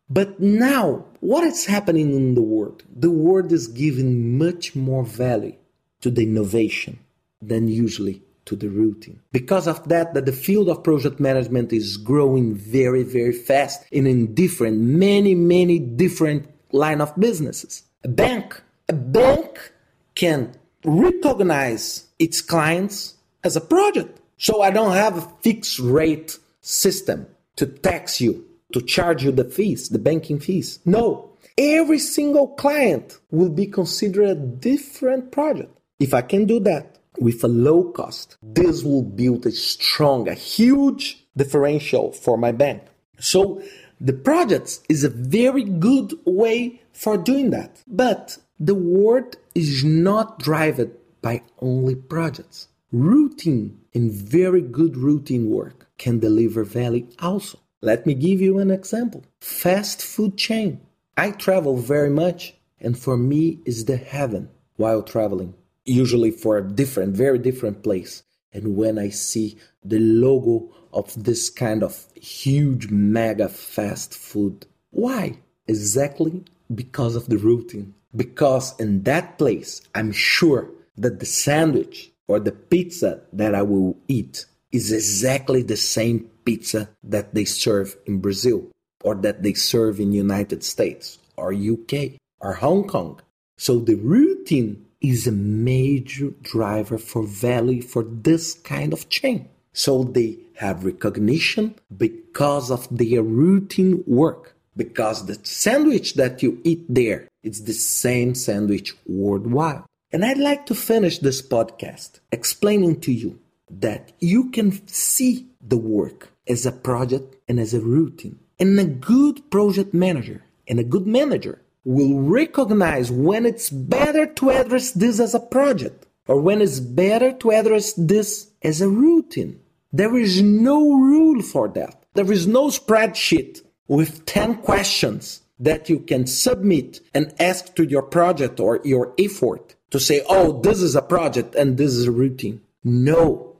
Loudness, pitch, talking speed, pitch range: -20 LUFS, 150 Hz, 145 wpm, 120-195 Hz